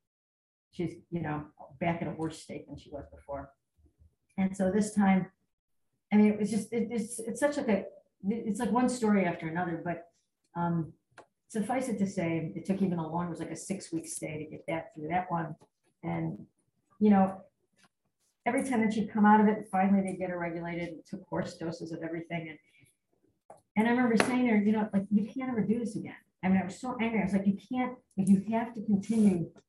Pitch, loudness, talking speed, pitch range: 190 Hz, -31 LUFS, 220 wpm, 170-215 Hz